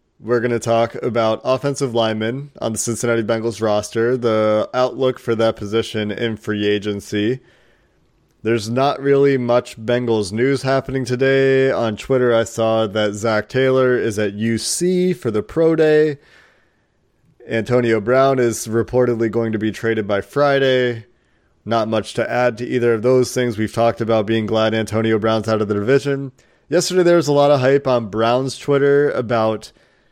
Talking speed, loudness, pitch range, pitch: 165 wpm, -18 LUFS, 110-130 Hz, 115 Hz